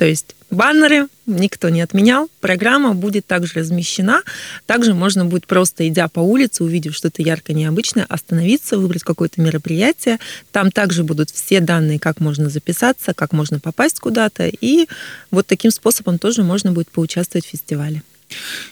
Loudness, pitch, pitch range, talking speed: -16 LUFS, 180 Hz, 165-220 Hz, 150 wpm